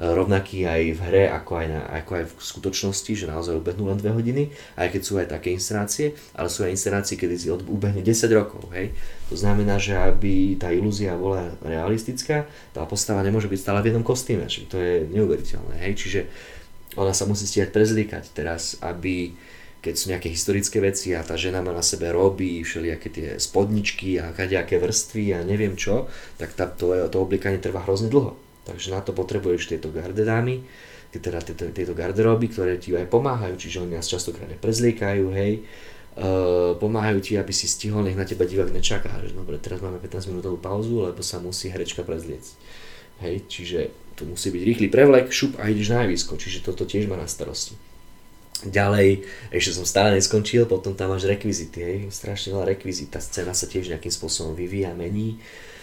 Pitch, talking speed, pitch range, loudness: 95 Hz, 185 wpm, 90-105 Hz, -24 LUFS